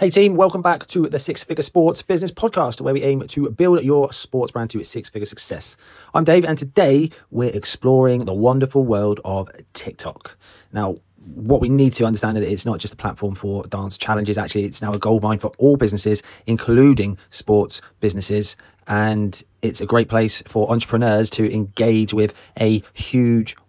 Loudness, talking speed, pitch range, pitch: -19 LUFS, 185 wpm, 105-135 Hz, 110 Hz